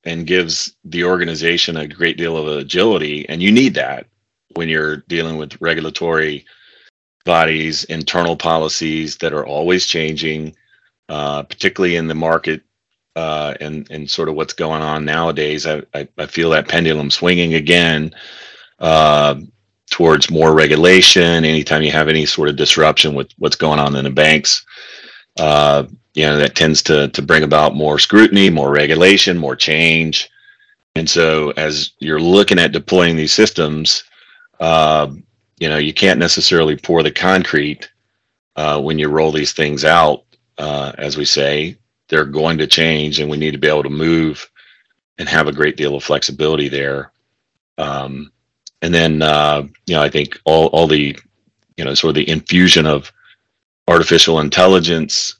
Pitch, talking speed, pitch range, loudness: 80 Hz, 160 wpm, 75-85 Hz, -13 LUFS